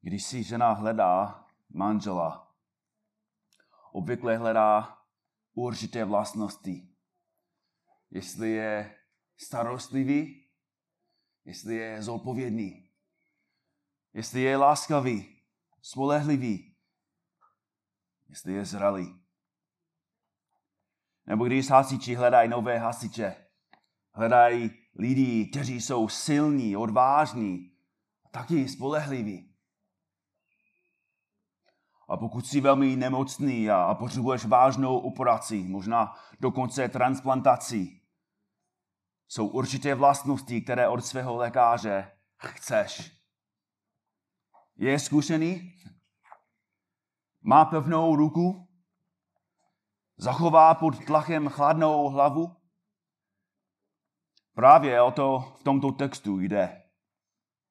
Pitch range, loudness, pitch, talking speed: 110-145 Hz, -26 LUFS, 125 Hz, 75 wpm